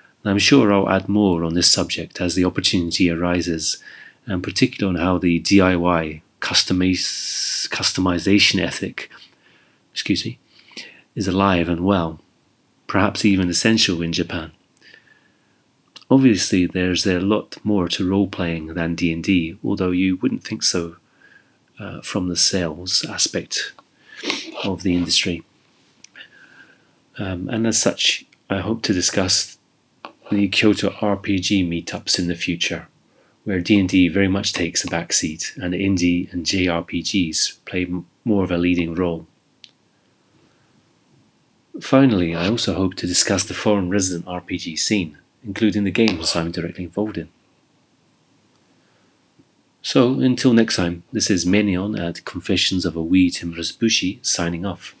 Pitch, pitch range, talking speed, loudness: 90 Hz, 85-100 Hz, 130 wpm, -19 LUFS